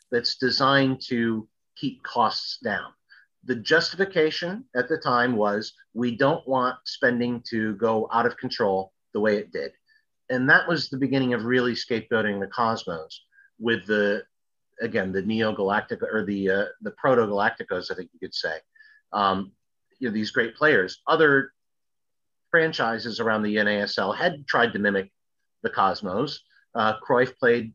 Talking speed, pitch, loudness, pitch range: 150 wpm, 120 Hz, -24 LUFS, 110-135 Hz